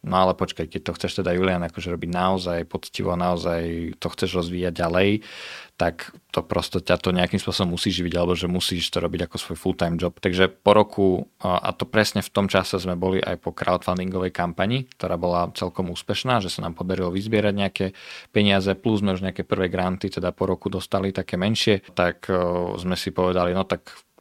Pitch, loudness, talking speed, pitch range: 95 Hz, -24 LUFS, 200 wpm, 90-100 Hz